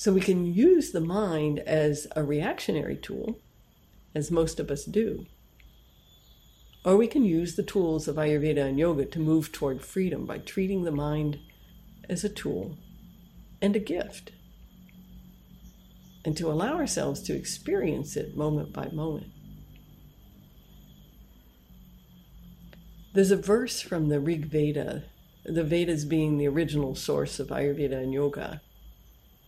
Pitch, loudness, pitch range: 155 Hz, -28 LUFS, 145-180 Hz